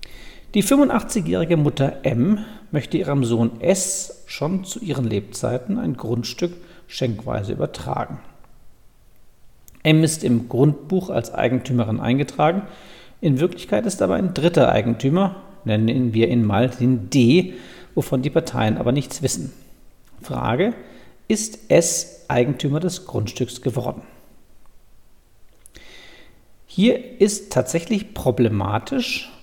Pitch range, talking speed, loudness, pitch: 120-185 Hz, 110 wpm, -21 LUFS, 140 Hz